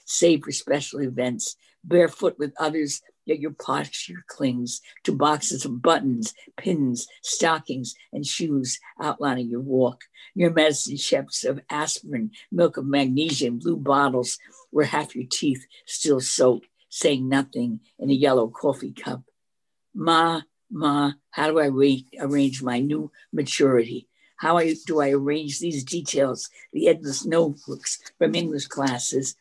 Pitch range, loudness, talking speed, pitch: 135-160 Hz, -24 LUFS, 140 wpm, 145 Hz